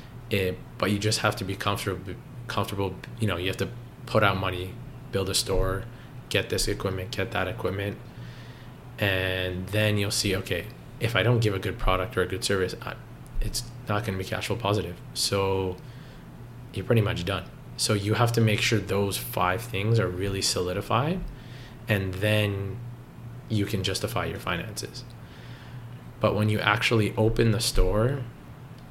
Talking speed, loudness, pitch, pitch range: 170 wpm, -27 LUFS, 105 Hz, 95-120 Hz